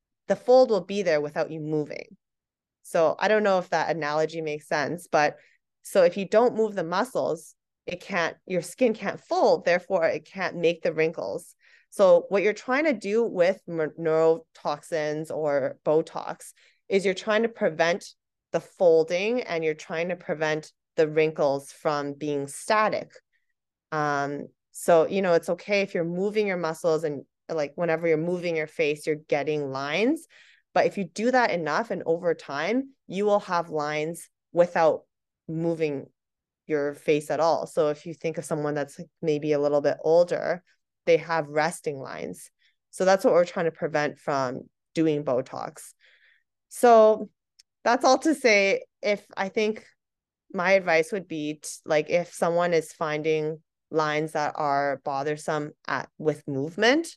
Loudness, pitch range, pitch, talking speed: -25 LUFS, 155-205 Hz, 170 Hz, 165 wpm